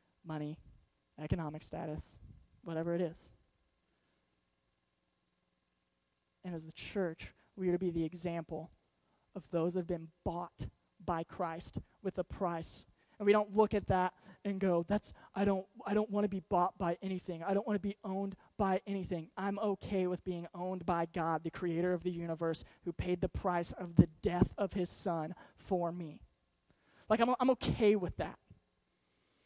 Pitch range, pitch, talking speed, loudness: 160-195 Hz, 175 Hz, 170 wpm, -36 LUFS